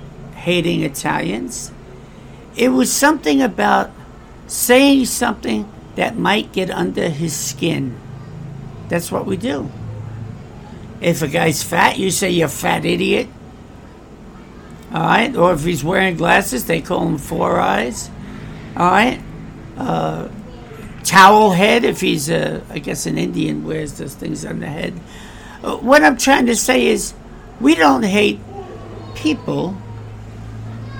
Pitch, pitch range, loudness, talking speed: 170 Hz, 130-215 Hz, -16 LUFS, 130 wpm